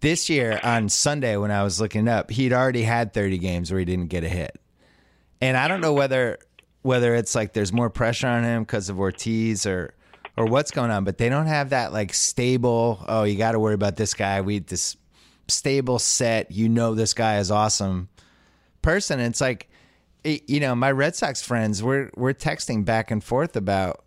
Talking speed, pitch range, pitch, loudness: 210 wpm, 105-130 Hz, 115 Hz, -23 LUFS